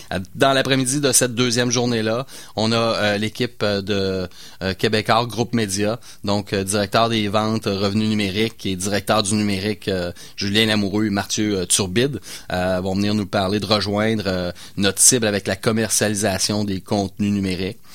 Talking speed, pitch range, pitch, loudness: 165 wpm, 95-110 Hz, 105 Hz, -20 LUFS